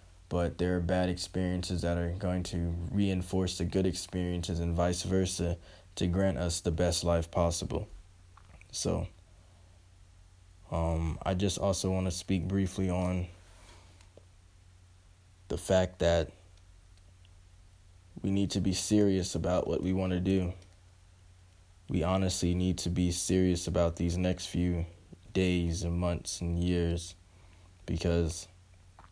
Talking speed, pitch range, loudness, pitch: 130 wpm, 85-90 Hz, -31 LUFS, 90 Hz